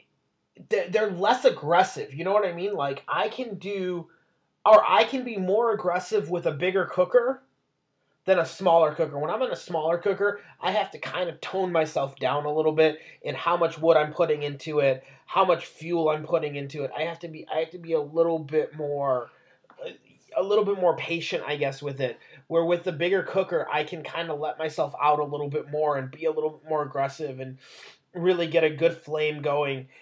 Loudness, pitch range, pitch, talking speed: -26 LUFS, 150-185 Hz, 165 Hz, 220 wpm